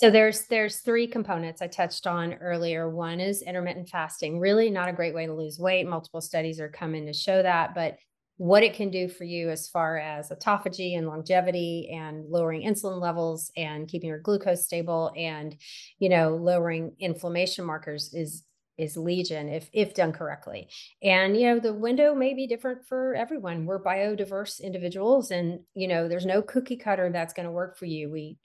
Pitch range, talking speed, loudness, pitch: 165-195 Hz, 190 wpm, -27 LUFS, 175 Hz